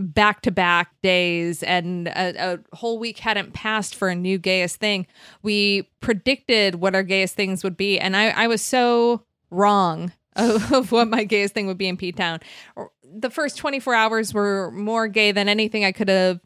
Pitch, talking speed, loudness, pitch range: 200 Hz, 195 wpm, -21 LUFS, 185-225 Hz